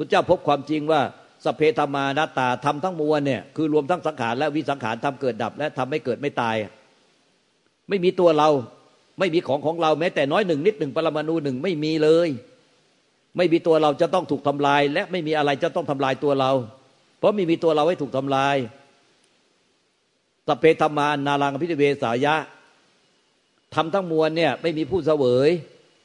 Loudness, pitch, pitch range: -22 LUFS, 150 Hz, 140-160 Hz